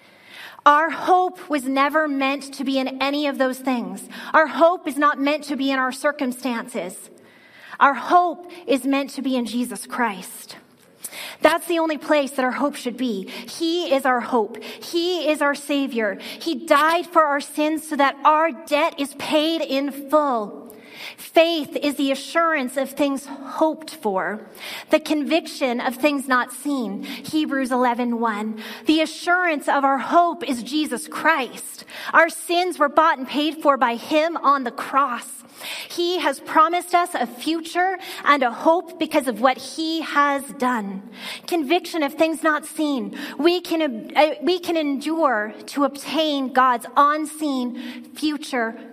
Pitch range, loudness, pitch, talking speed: 255-315 Hz, -21 LUFS, 285 Hz, 155 wpm